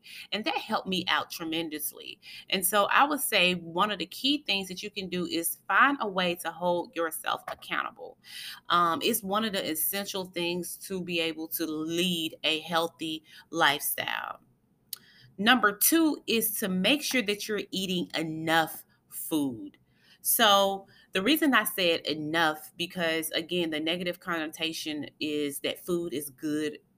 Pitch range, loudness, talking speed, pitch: 165-205 Hz, -28 LUFS, 155 wpm, 175 Hz